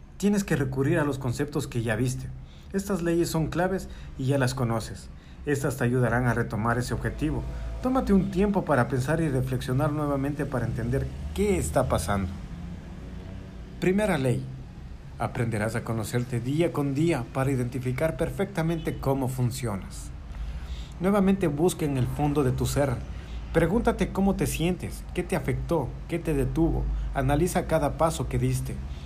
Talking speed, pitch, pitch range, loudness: 150 wpm, 135 Hz, 115-165 Hz, -27 LUFS